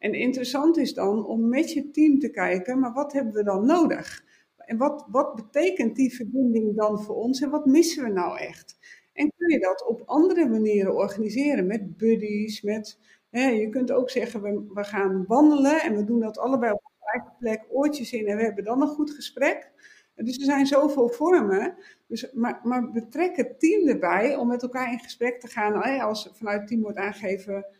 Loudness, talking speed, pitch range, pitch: -24 LUFS, 200 wpm, 215-285 Hz, 245 Hz